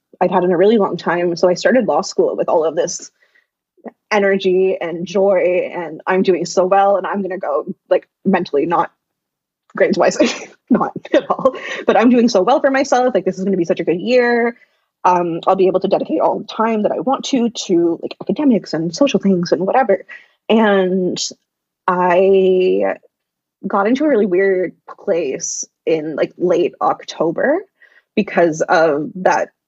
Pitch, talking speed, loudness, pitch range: 195 Hz, 180 wpm, -16 LUFS, 180-250 Hz